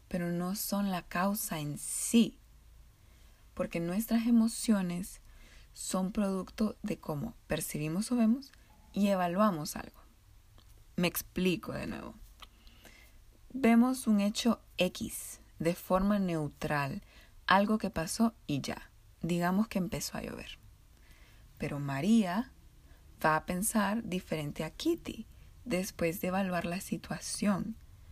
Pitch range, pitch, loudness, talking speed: 155-215 Hz, 185 Hz, -32 LUFS, 115 wpm